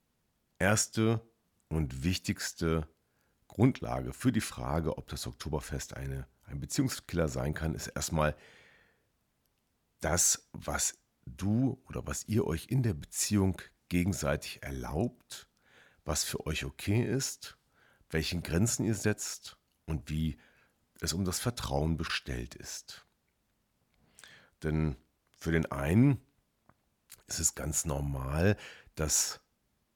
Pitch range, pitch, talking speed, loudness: 75-105 Hz, 80 Hz, 110 wpm, -32 LUFS